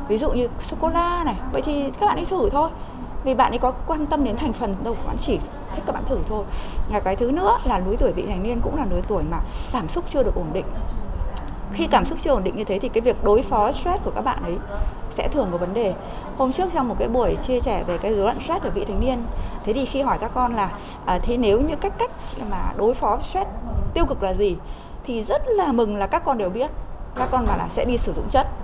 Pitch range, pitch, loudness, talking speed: 210-320 Hz, 255 Hz, -23 LUFS, 275 wpm